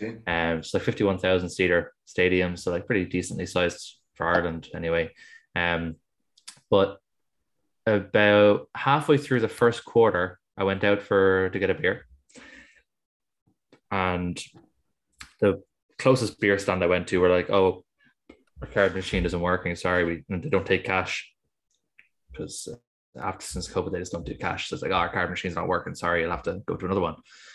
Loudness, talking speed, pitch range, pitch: -25 LUFS, 175 wpm, 85-100 Hz, 90 Hz